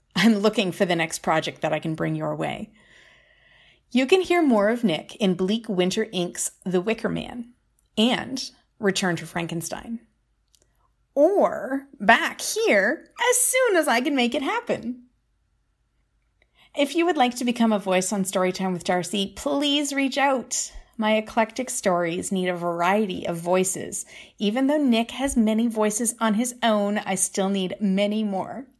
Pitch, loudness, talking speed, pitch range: 220 Hz, -23 LUFS, 160 wpm, 185-255 Hz